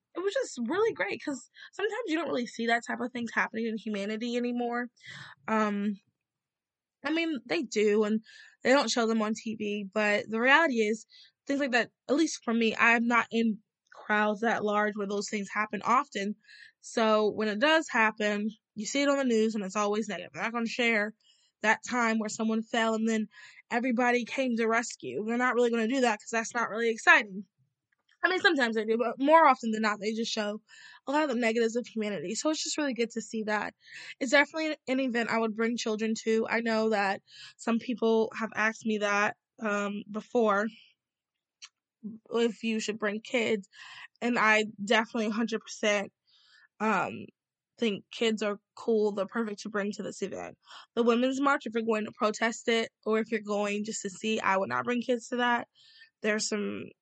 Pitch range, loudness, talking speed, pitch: 210-245 Hz, -29 LUFS, 200 wpm, 225 Hz